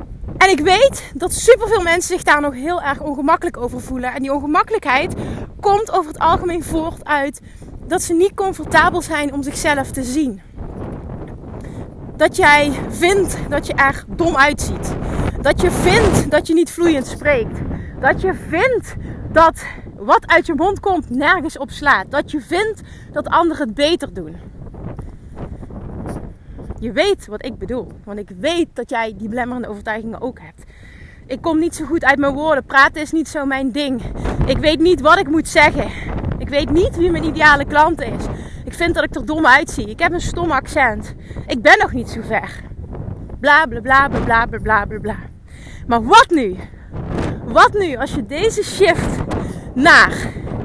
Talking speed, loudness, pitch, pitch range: 175 wpm, -15 LUFS, 310 Hz, 275-345 Hz